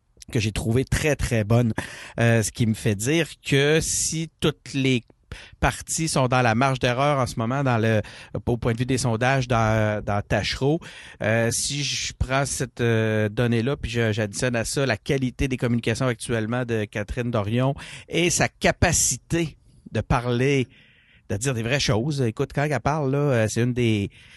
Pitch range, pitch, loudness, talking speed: 115-140 Hz, 125 Hz, -23 LUFS, 180 wpm